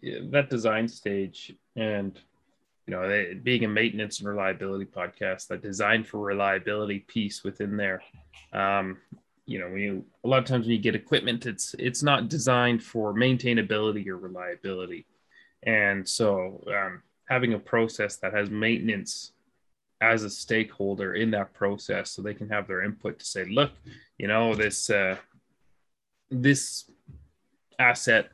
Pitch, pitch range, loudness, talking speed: 105 Hz, 100-115 Hz, -27 LUFS, 150 wpm